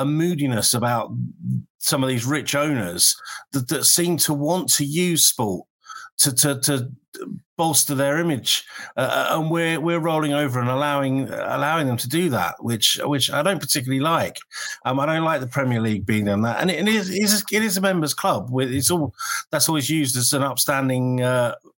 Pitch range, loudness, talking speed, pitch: 130-165 Hz, -20 LUFS, 190 wpm, 145 Hz